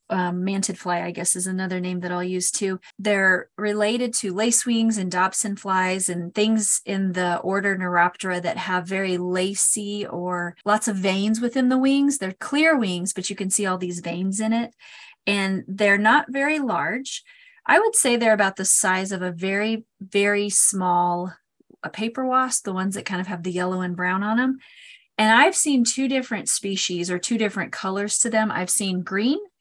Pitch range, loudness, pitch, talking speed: 185-225 Hz, -22 LUFS, 200 Hz, 195 wpm